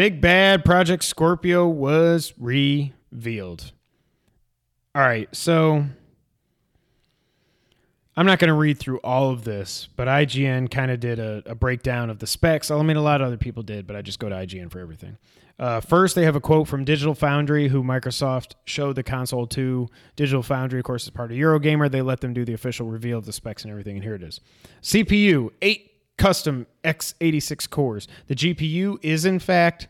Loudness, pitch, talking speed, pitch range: -21 LUFS, 135 Hz, 190 wpm, 120-155 Hz